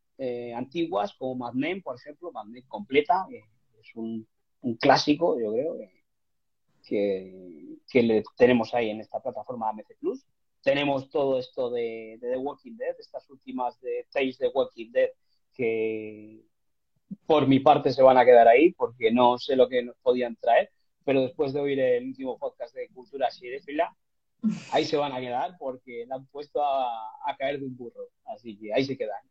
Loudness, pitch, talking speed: -26 LUFS, 130 Hz, 185 wpm